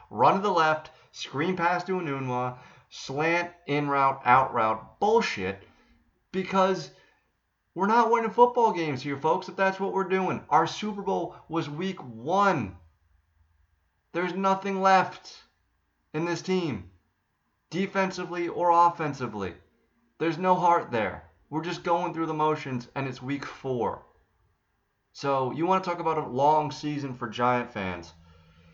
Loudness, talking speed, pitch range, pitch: -27 LUFS, 140 wpm, 120-180 Hz, 155 Hz